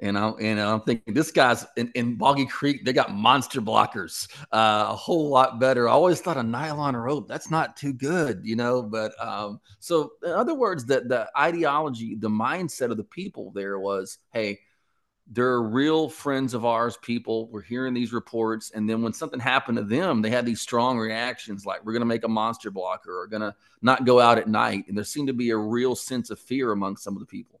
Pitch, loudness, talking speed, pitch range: 120 Hz, -25 LUFS, 220 wpm, 110-130 Hz